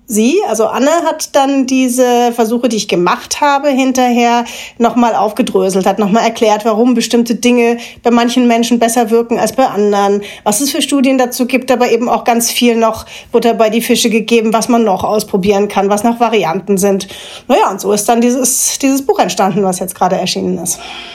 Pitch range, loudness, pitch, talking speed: 210-250 Hz, -12 LUFS, 235 Hz, 195 wpm